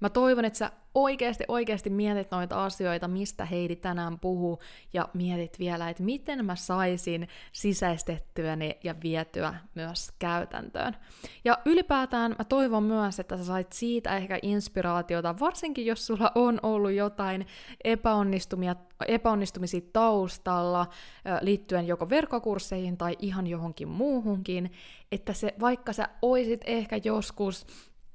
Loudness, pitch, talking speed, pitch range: -29 LUFS, 195 Hz, 125 wpm, 180-225 Hz